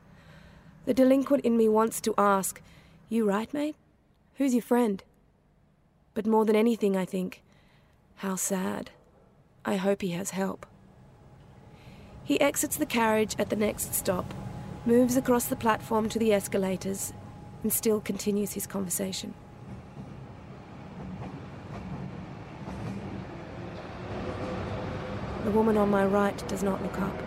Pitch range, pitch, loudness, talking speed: 195-230 Hz, 215 Hz, -28 LUFS, 120 wpm